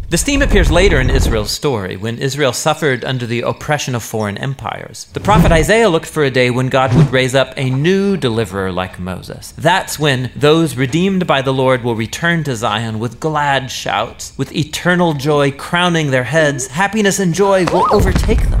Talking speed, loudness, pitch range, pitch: 190 wpm, -14 LUFS, 125-165 Hz, 140 Hz